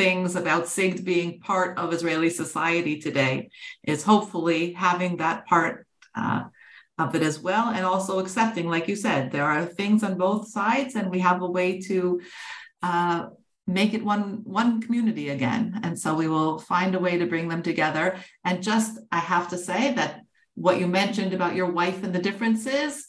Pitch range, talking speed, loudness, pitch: 170-205 Hz, 185 wpm, -25 LUFS, 180 Hz